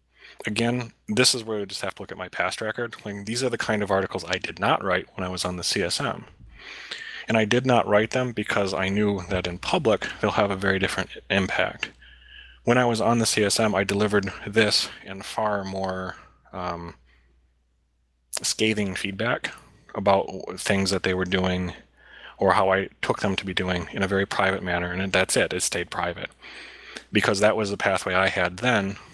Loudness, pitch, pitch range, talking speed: -24 LUFS, 95 Hz, 90-110 Hz, 200 wpm